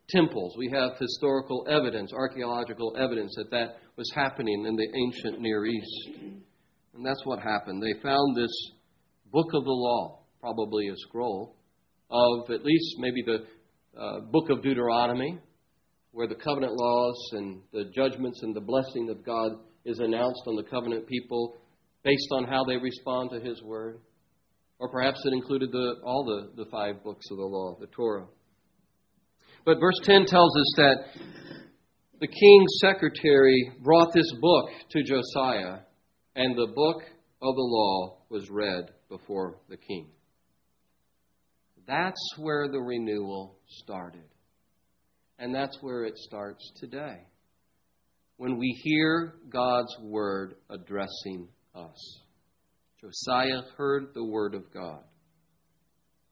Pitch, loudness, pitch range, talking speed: 120 Hz, -27 LUFS, 110-135 Hz, 135 wpm